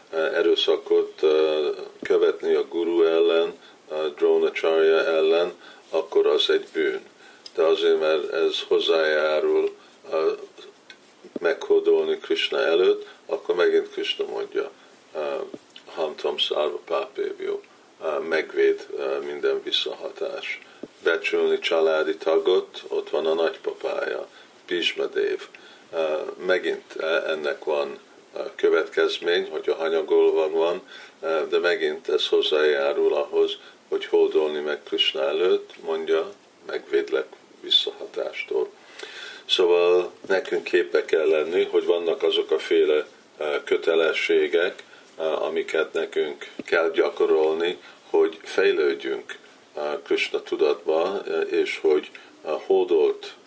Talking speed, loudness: 90 wpm, -23 LUFS